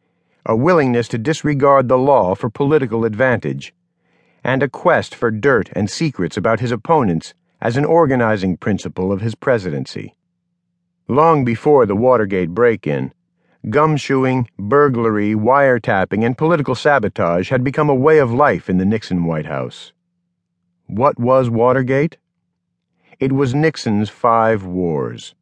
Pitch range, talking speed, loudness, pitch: 110-150 Hz, 135 wpm, -16 LUFS, 130 Hz